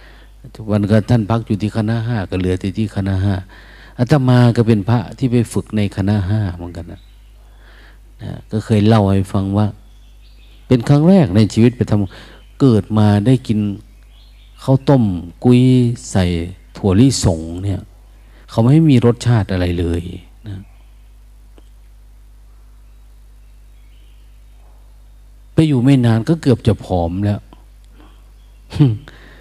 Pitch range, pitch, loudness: 95-120 Hz, 110 Hz, -15 LUFS